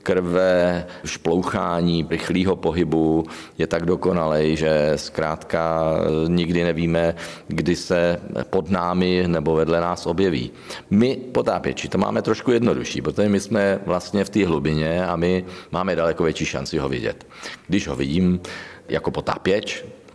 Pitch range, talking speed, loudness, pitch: 80-90 Hz, 135 wpm, -21 LUFS, 85 Hz